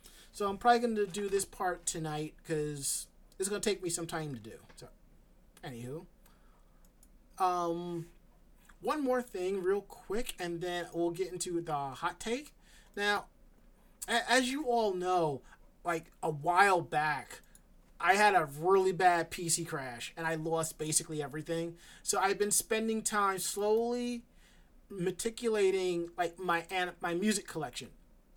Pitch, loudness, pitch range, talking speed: 180 Hz, -33 LUFS, 165-205 Hz, 150 wpm